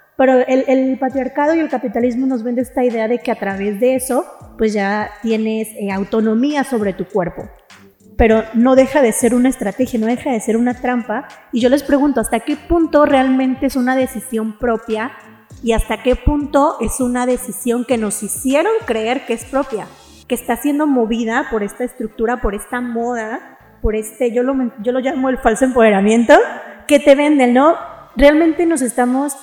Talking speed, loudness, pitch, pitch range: 185 wpm, -16 LUFS, 245 Hz, 225-265 Hz